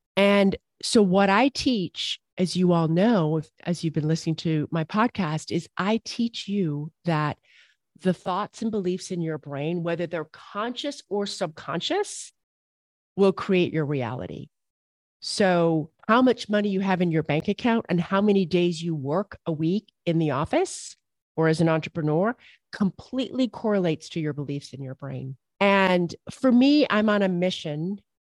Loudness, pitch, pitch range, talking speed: -25 LUFS, 180 Hz, 160-205 Hz, 165 wpm